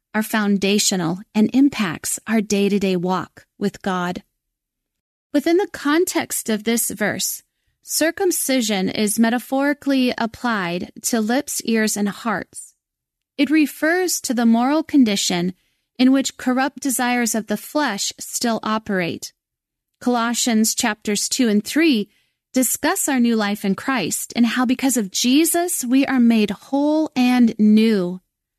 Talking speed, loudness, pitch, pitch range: 130 wpm, -19 LUFS, 235 Hz, 210-275 Hz